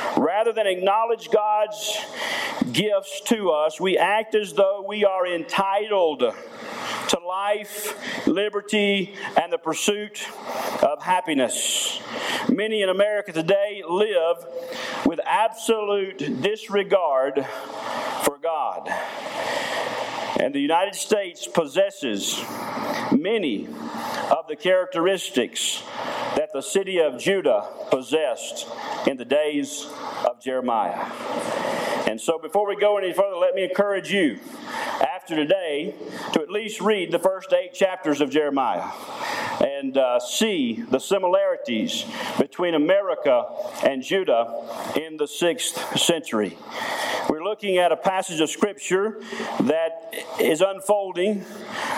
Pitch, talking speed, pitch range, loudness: 205 Hz, 115 wpm, 180-230 Hz, -23 LUFS